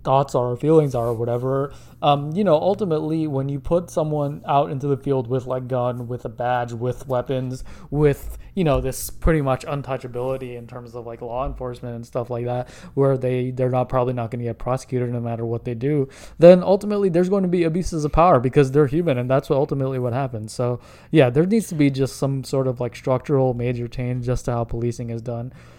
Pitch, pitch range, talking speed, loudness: 130 Hz, 125-145 Hz, 225 wpm, -21 LUFS